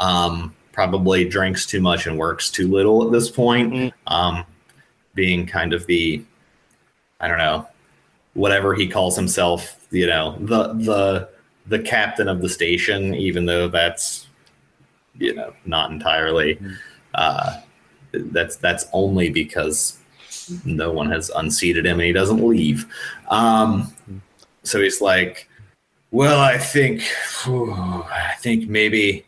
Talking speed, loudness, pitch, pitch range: 135 wpm, -19 LUFS, 95 Hz, 85-110 Hz